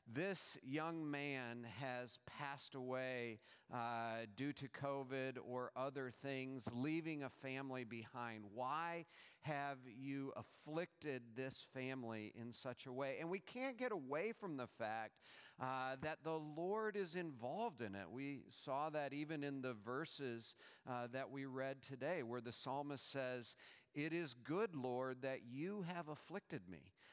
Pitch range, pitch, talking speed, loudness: 125-150 Hz, 135 Hz, 150 wpm, -48 LUFS